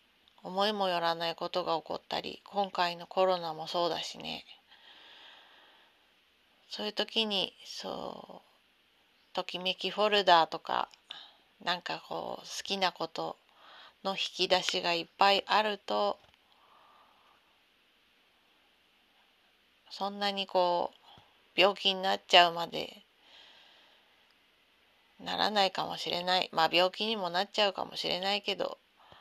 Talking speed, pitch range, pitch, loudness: 235 characters per minute, 175-200 Hz, 185 Hz, -31 LUFS